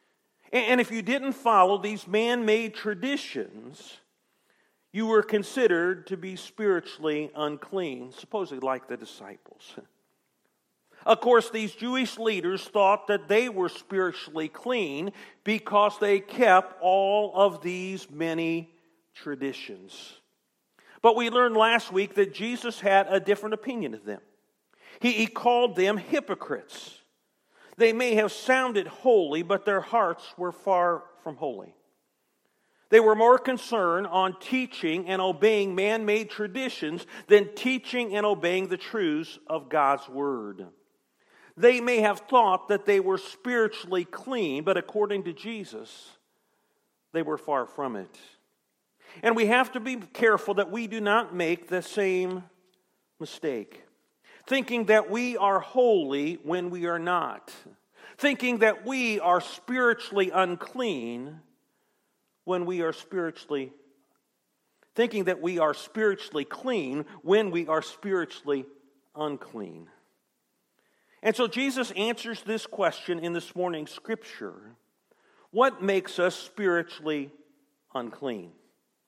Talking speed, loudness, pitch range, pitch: 125 wpm, -26 LUFS, 175-225 Hz, 200 Hz